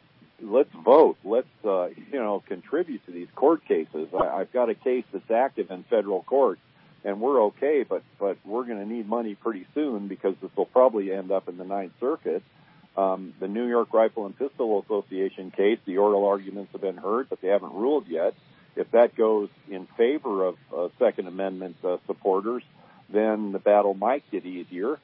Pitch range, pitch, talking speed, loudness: 95-130 Hz, 105 Hz, 190 wpm, -26 LUFS